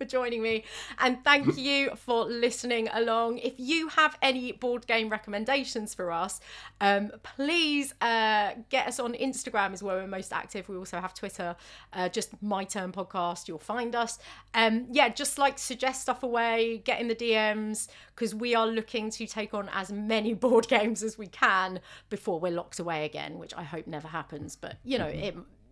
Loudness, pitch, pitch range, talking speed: -29 LUFS, 225 Hz, 195-250 Hz, 190 wpm